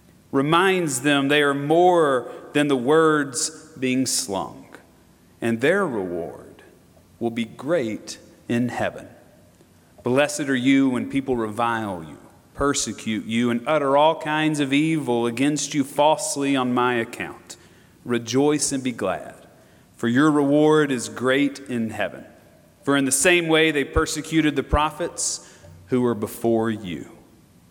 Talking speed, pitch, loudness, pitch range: 135 wpm, 135 Hz, -21 LUFS, 120-150 Hz